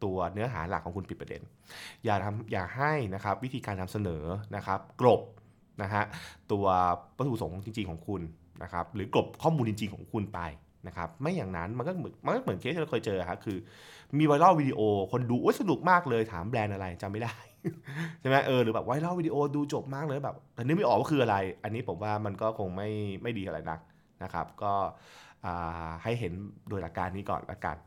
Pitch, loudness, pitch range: 105 Hz, -31 LUFS, 95-125 Hz